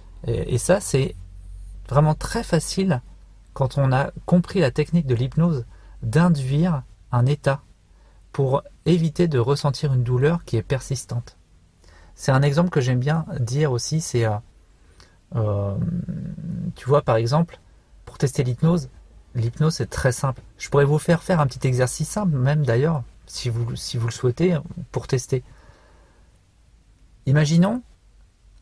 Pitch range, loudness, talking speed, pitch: 110-155 Hz, -22 LUFS, 140 wpm, 130 Hz